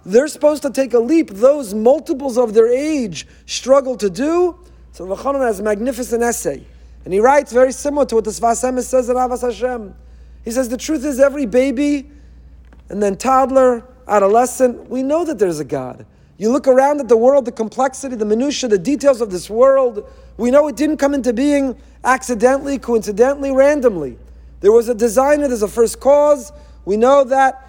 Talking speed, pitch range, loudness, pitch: 185 wpm, 230-280 Hz, -16 LUFS, 255 Hz